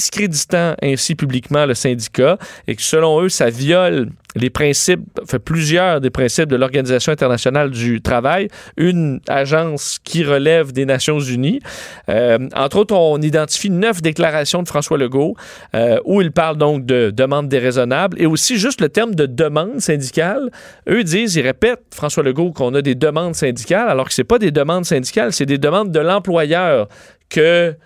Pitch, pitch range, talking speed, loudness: 155 Hz, 135-175 Hz, 170 wpm, -16 LUFS